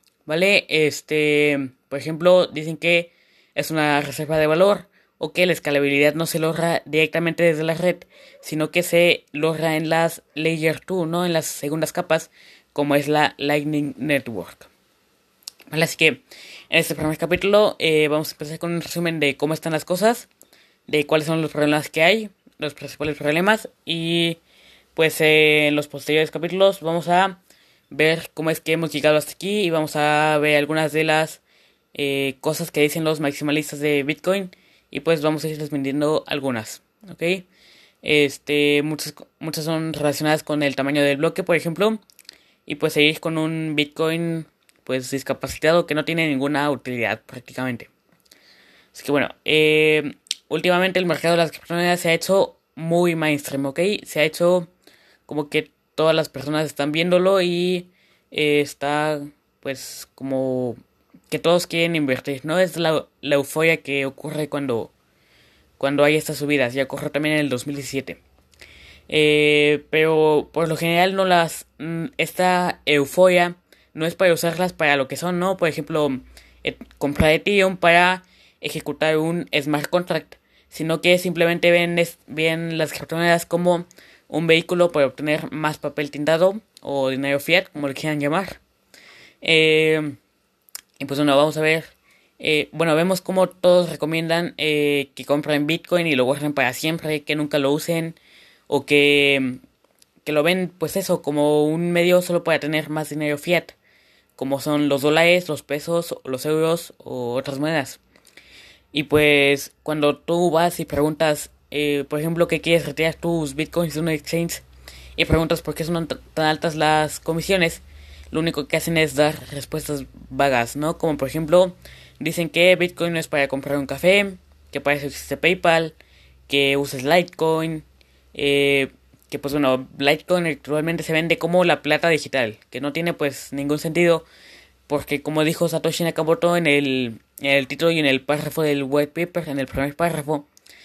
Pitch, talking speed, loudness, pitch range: 155 Hz, 165 wpm, -20 LUFS, 145-165 Hz